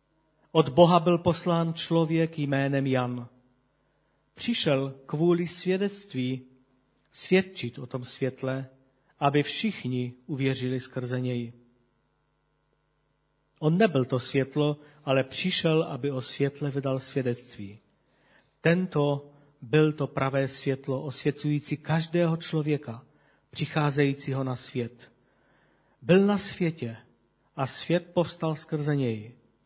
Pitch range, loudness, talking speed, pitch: 130-160 Hz, -27 LUFS, 100 wpm, 140 Hz